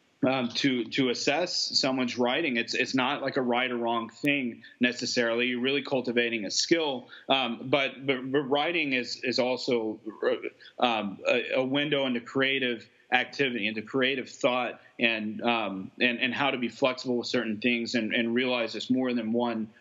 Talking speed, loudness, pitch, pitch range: 175 wpm, -27 LUFS, 125 Hz, 120-135 Hz